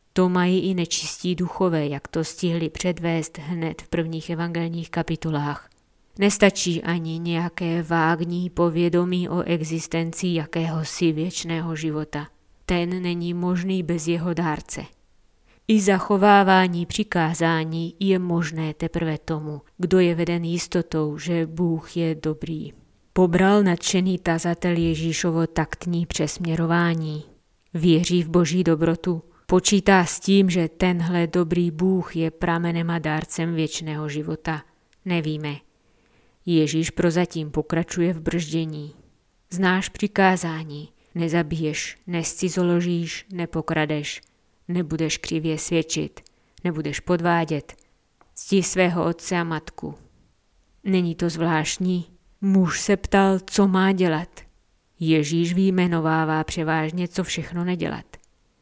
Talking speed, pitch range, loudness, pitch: 105 wpm, 160-180 Hz, -23 LUFS, 170 Hz